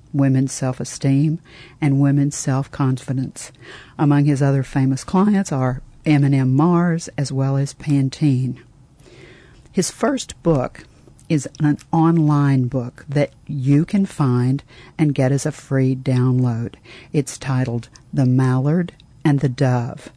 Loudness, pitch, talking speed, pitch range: -19 LUFS, 140 Hz, 130 wpm, 130-150 Hz